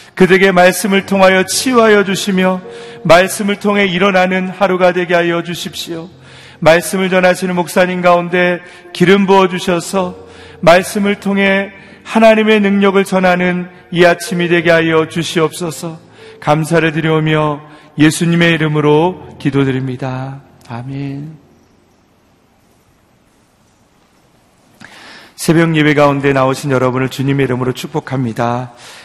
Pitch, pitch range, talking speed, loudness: 175 Hz, 150-185 Hz, 275 characters per minute, -12 LUFS